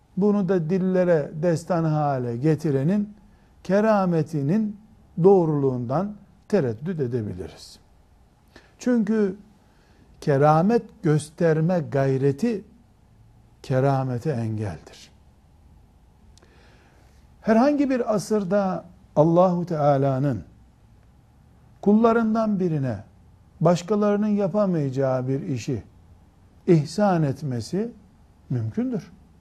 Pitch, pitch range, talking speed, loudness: 160 Hz, 130-200 Hz, 60 wpm, -23 LUFS